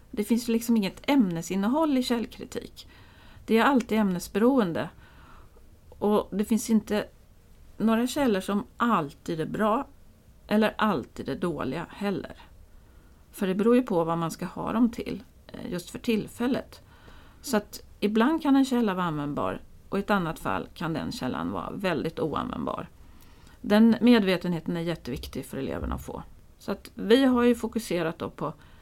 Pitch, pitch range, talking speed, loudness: 210 Hz, 175-235 Hz, 155 wpm, -27 LUFS